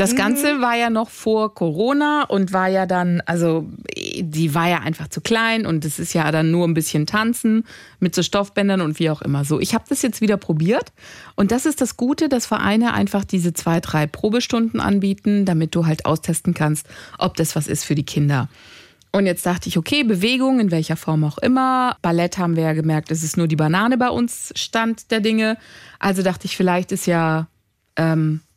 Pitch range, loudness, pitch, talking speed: 160-225 Hz, -19 LUFS, 185 Hz, 210 wpm